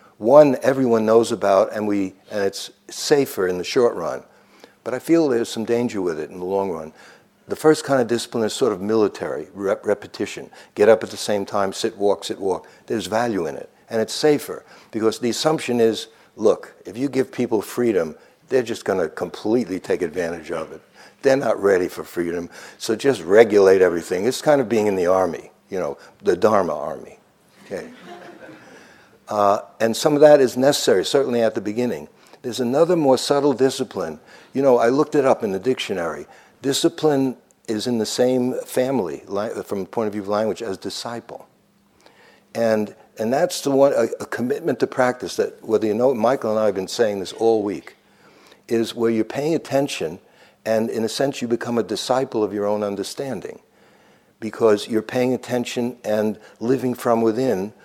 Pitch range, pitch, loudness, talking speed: 105-130 Hz, 115 Hz, -20 LUFS, 190 wpm